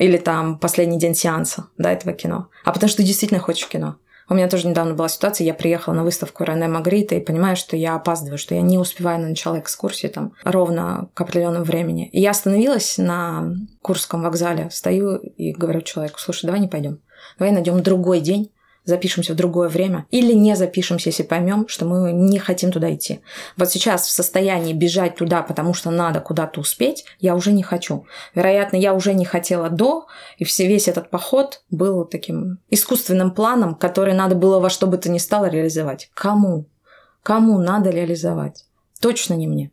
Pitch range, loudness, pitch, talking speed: 170-190 Hz, -19 LUFS, 180 Hz, 190 wpm